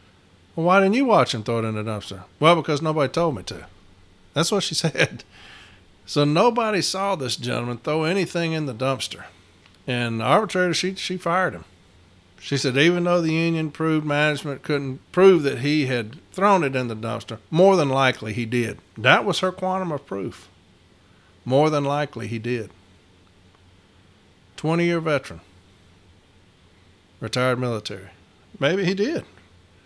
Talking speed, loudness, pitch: 155 wpm, -22 LUFS, 125 Hz